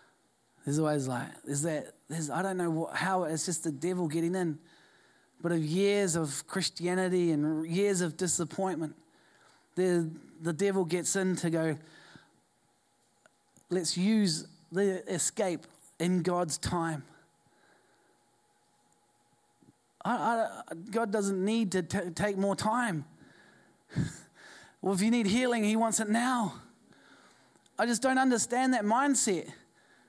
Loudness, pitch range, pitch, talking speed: -31 LUFS, 165-210 Hz, 185 Hz, 130 wpm